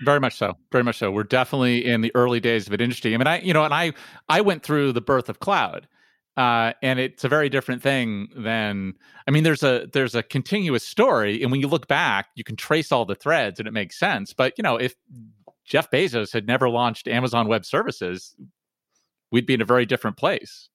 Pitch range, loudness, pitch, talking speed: 115-135 Hz, -22 LUFS, 125 Hz, 230 wpm